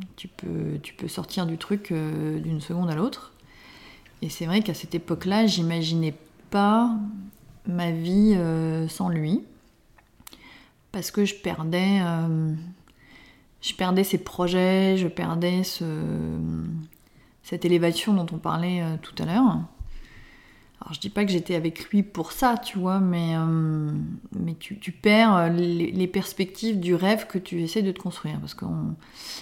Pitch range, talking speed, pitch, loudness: 165-195 Hz, 155 wpm, 175 Hz, -25 LUFS